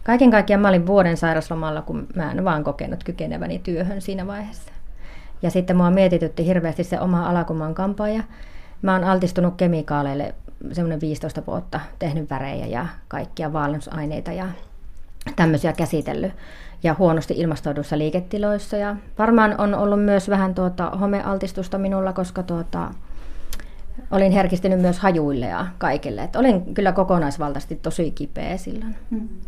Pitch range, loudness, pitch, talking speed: 155-195 Hz, -22 LUFS, 180 Hz, 145 wpm